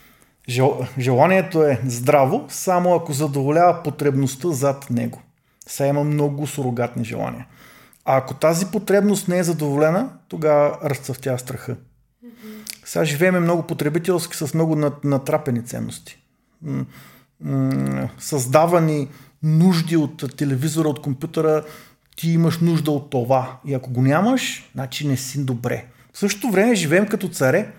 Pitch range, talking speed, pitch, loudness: 130-170 Hz, 125 wpm, 145 Hz, -20 LUFS